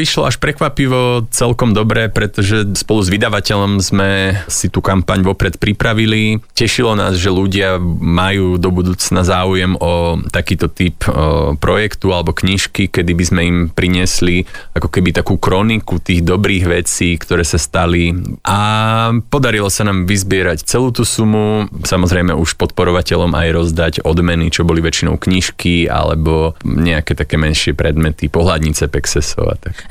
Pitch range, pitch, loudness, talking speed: 85-105 Hz, 90 Hz, -14 LUFS, 140 wpm